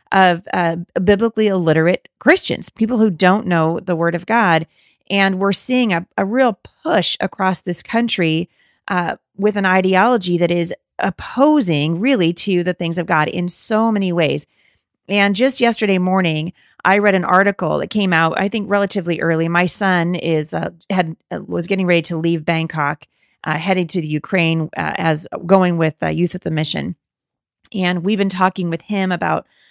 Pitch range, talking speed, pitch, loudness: 165-200 Hz, 180 wpm, 180 Hz, -17 LUFS